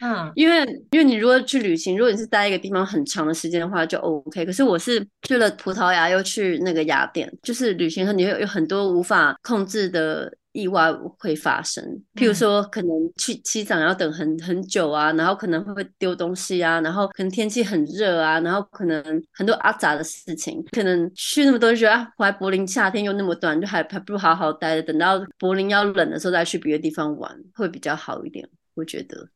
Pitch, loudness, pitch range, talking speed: 190 Hz, -21 LUFS, 165-215 Hz, 325 characters per minute